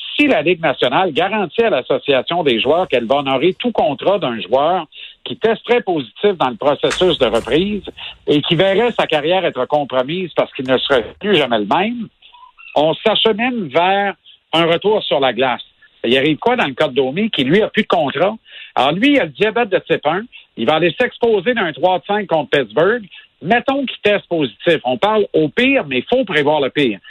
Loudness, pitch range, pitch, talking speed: -16 LUFS, 155-230 Hz, 195 Hz, 205 wpm